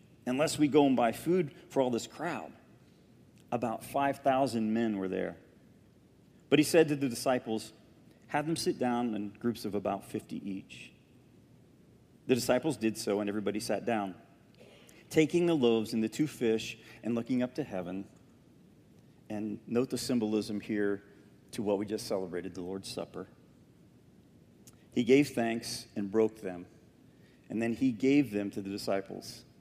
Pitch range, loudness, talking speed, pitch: 105-135 Hz, -32 LUFS, 160 wpm, 115 Hz